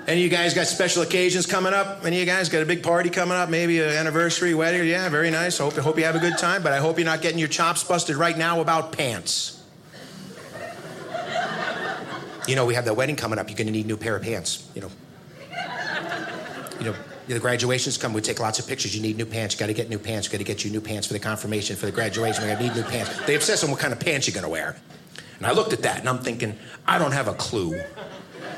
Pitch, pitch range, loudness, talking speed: 150 Hz, 115-170 Hz, -23 LUFS, 270 wpm